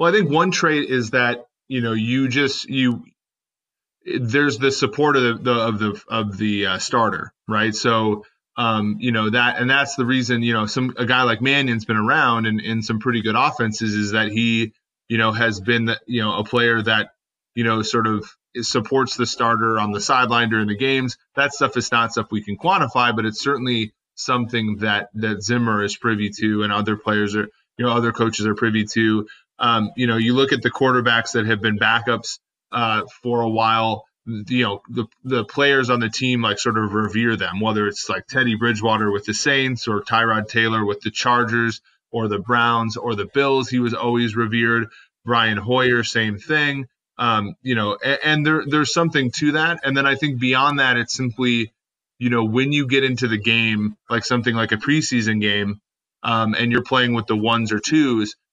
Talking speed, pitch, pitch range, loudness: 205 wpm, 115 Hz, 110-125 Hz, -19 LUFS